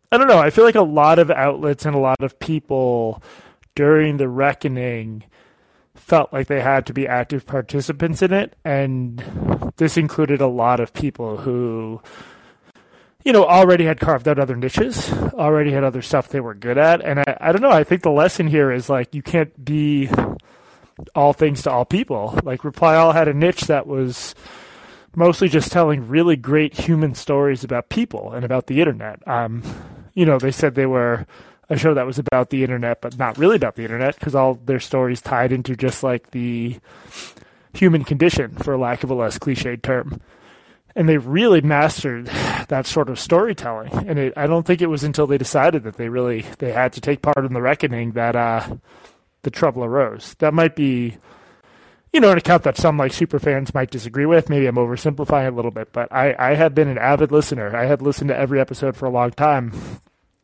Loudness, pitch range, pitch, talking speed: -18 LUFS, 125-155 Hz, 140 Hz, 205 wpm